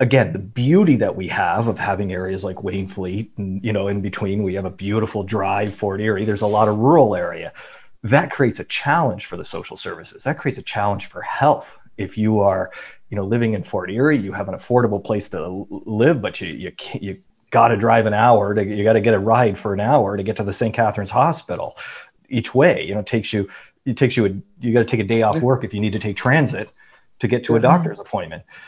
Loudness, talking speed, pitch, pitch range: -19 LUFS, 240 wpm, 105 Hz, 100-115 Hz